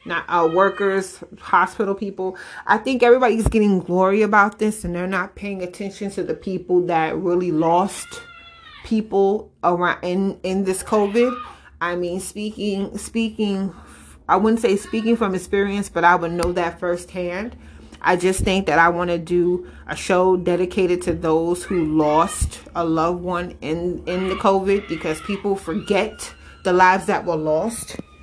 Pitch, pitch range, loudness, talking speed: 185 Hz, 175-205 Hz, -20 LUFS, 160 wpm